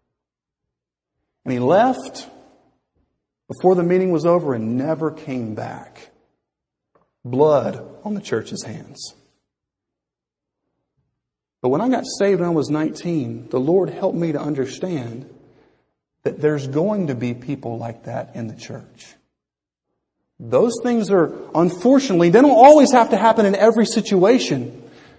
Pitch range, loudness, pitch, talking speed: 120-195 Hz, -18 LUFS, 155 Hz, 135 wpm